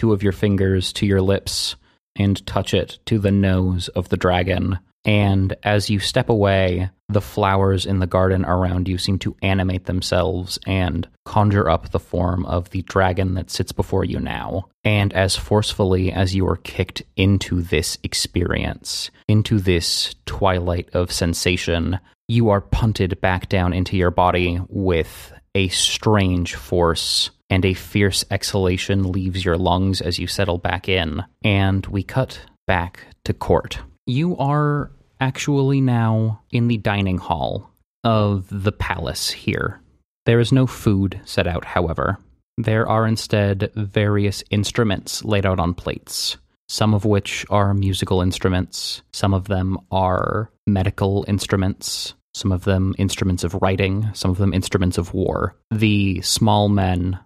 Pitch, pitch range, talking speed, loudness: 95 Hz, 90-105 Hz, 150 wpm, -20 LUFS